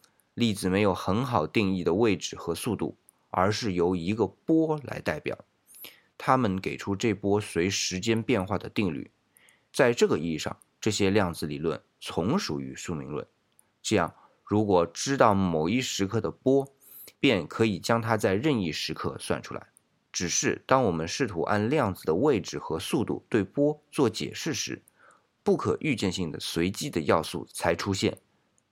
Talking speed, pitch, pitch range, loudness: 240 characters per minute, 100 Hz, 95-115 Hz, -27 LUFS